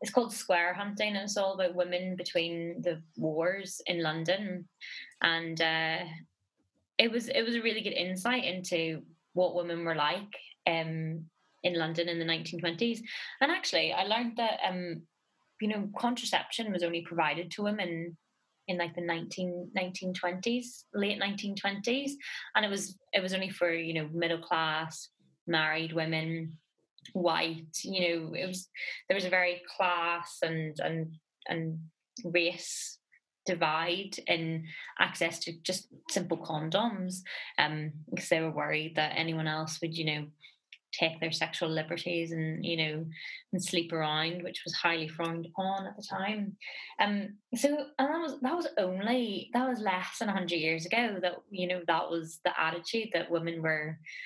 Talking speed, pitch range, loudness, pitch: 160 wpm, 165-195 Hz, -32 LUFS, 175 Hz